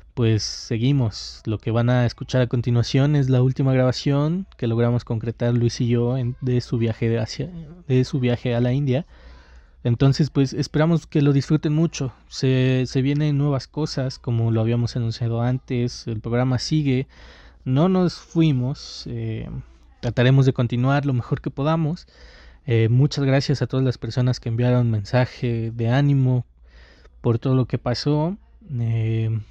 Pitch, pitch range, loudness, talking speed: 125 Hz, 115-140 Hz, -22 LUFS, 165 wpm